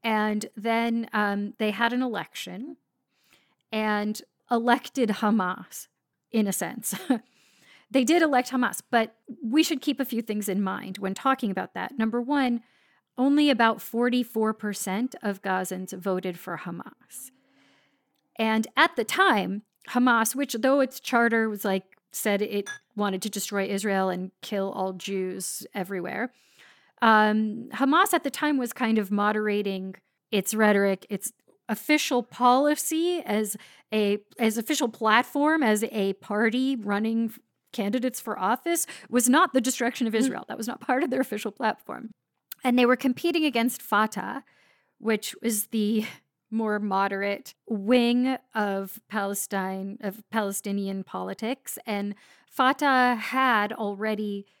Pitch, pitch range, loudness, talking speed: 225 Hz, 205-250 Hz, -26 LUFS, 135 wpm